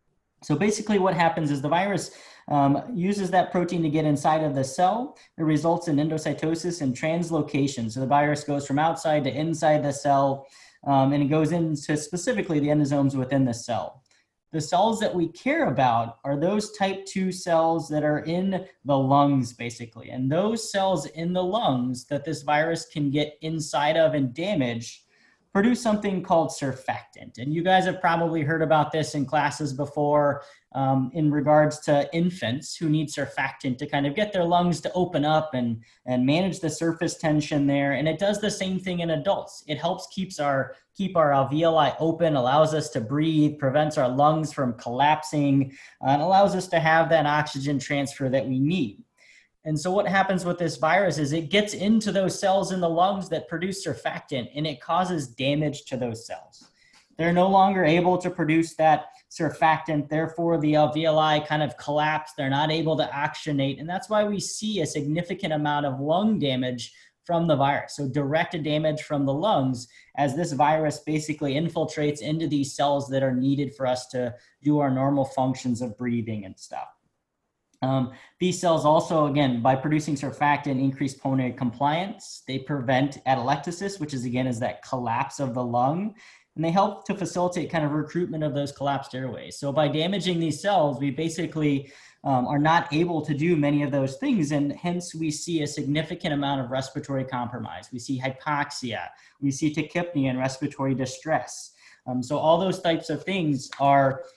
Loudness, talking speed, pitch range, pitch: -25 LUFS, 180 wpm, 140-165 Hz, 150 Hz